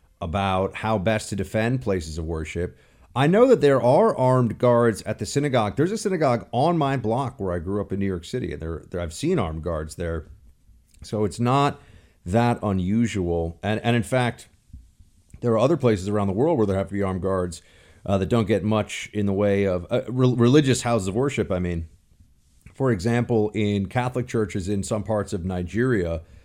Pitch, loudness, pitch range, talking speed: 105 Hz, -23 LUFS, 90-120 Hz, 205 wpm